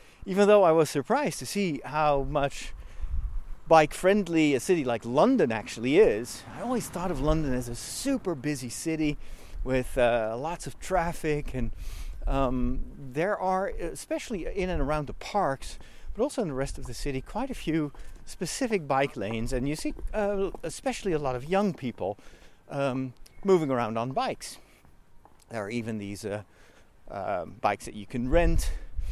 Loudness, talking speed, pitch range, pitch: -28 LUFS, 170 wpm, 120-185 Hz, 145 Hz